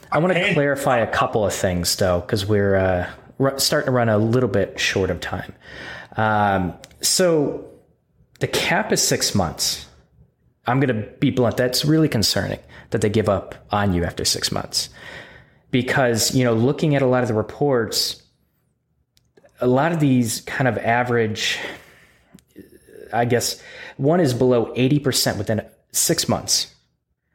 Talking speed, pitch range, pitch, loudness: 160 wpm, 105-135 Hz, 120 Hz, -20 LUFS